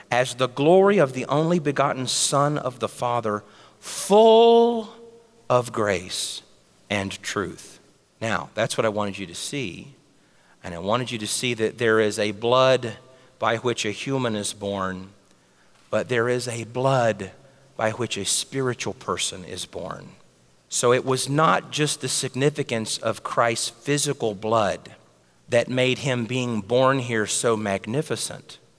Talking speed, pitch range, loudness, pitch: 150 wpm, 110-135 Hz, -23 LUFS, 125 Hz